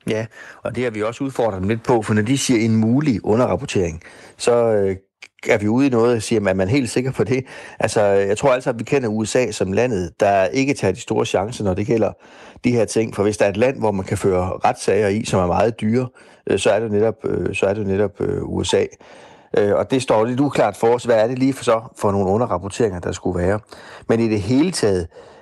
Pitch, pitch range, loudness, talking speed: 110 Hz, 100-125 Hz, -19 LUFS, 240 wpm